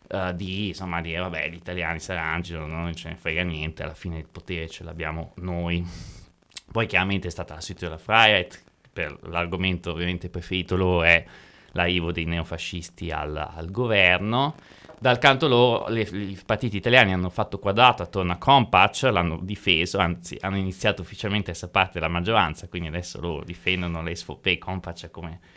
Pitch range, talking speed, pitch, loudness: 85-95 Hz, 170 wpm, 90 Hz, -24 LUFS